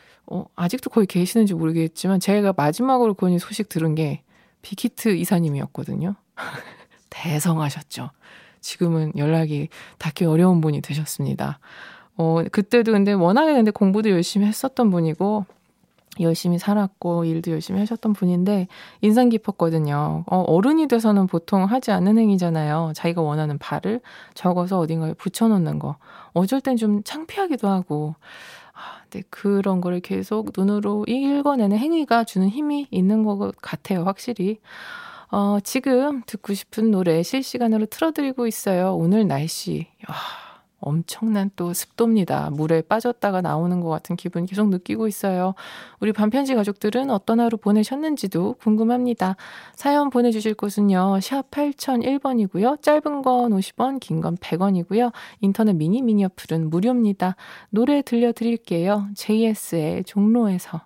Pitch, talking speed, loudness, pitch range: 200 Hz, 320 characters per minute, -21 LUFS, 175-230 Hz